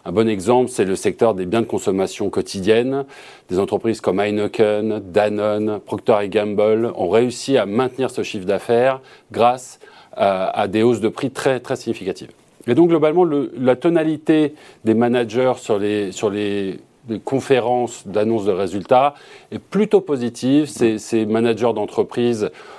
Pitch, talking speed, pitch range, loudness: 115 Hz, 155 wpm, 105-130 Hz, -19 LUFS